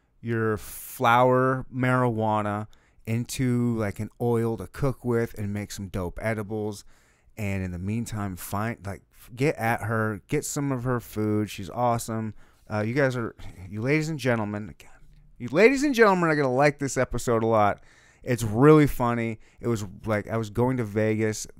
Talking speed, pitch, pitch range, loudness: 170 wpm, 115 Hz, 105-125 Hz, -25 LUFS